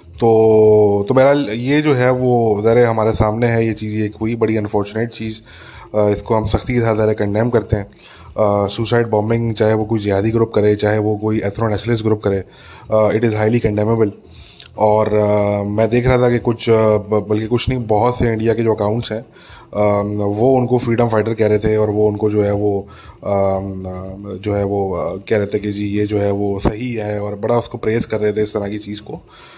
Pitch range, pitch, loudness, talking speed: 105-115 Hz, 110 Hz, -16 LUFS, 215 wpm